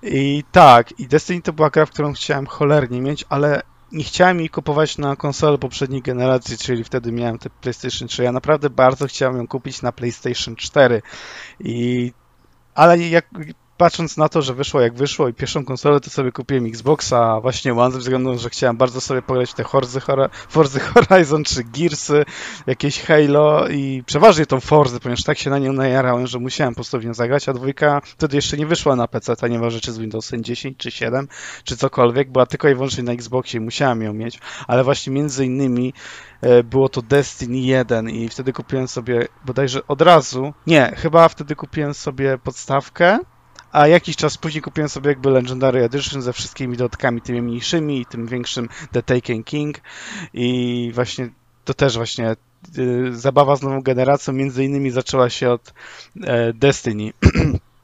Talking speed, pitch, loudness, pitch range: 180 wpm, 135 Hz, -18 LUFS, 125-145 Hz